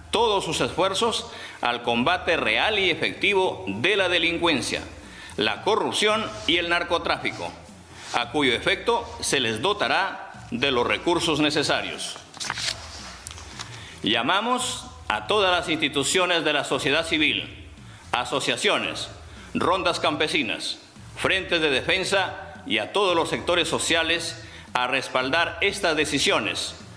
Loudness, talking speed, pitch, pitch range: -23 LUFS, 115 wpm, 170 Hz, 145-190 Hz